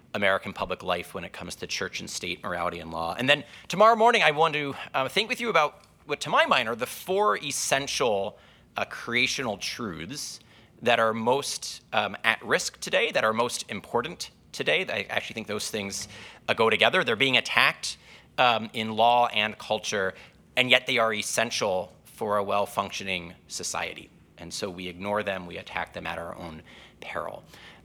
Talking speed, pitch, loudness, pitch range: 185 wpm, 110 Hz, -26 LUFS, 100-130 Hz